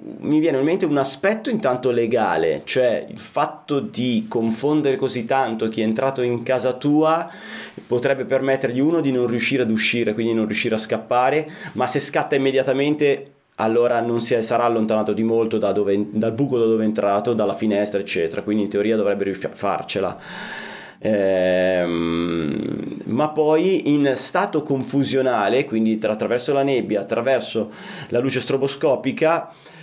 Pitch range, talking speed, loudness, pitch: 110-140 Hz, 155 wpm, -20 LUFS, 125 Hz